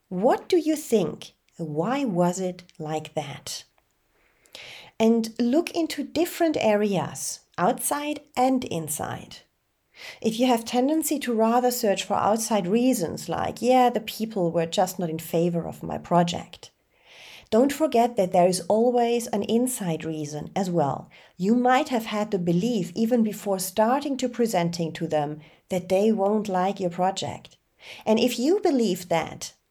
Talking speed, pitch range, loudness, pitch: 150 wpm, 175-245 Hz, -24 LUFS, 210 Hz